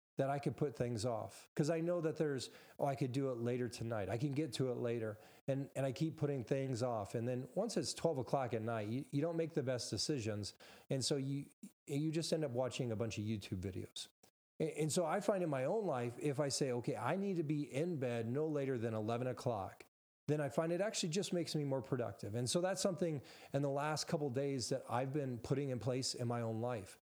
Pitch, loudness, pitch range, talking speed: 140 Hz, -40 LUFS, 120-155 Hz, 250 wpm